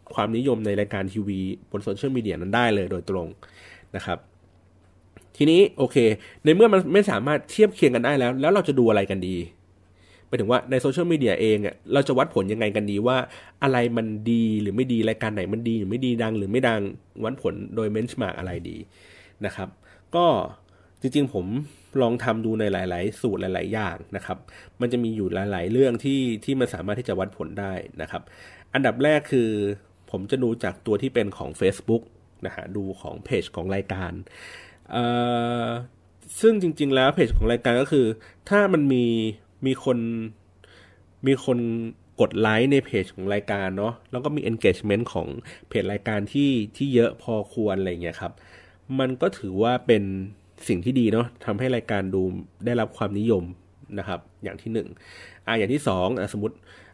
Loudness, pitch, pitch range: -24 LUFS, 110 Hz, 95-125 Hz